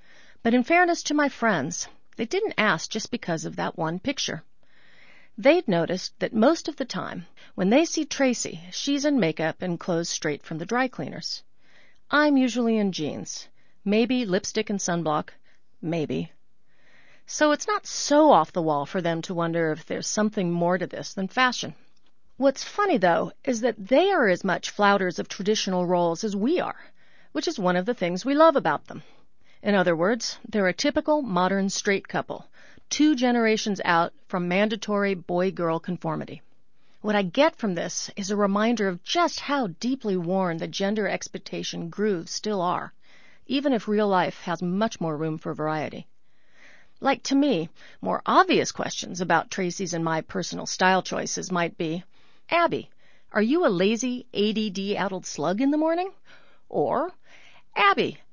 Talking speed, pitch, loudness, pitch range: 165 wpm, 205 Hz, -25 LUFS, 180-265 Hz